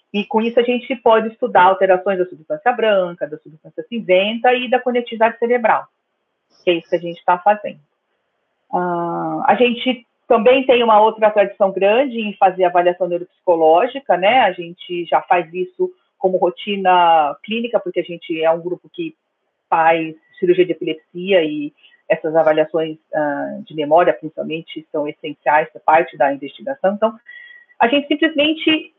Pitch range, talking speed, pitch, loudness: 170-245 Hz, 160 wpm, 195 Hz, -17 LUFS